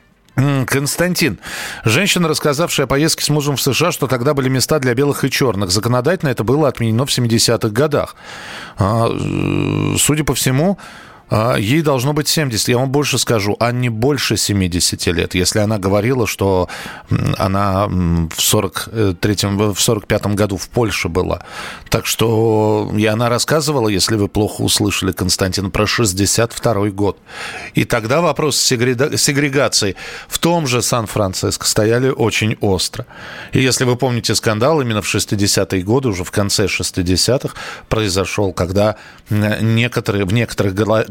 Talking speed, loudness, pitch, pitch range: 140 wpm, -16 LUFS, 115 Hz, 100-135 Hz